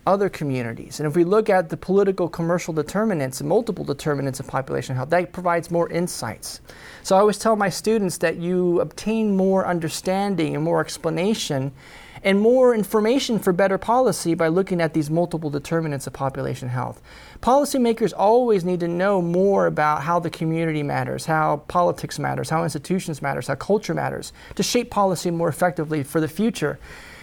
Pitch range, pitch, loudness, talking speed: 155-195 Hz, 175 Hz, -22 LUFS, 170 wpm